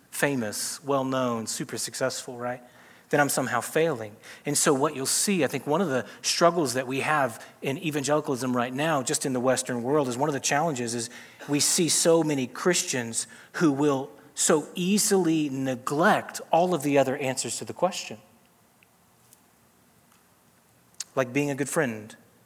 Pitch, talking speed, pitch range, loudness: 140 Hz, 165 wpm, 125-160 Hz, -26 LUFS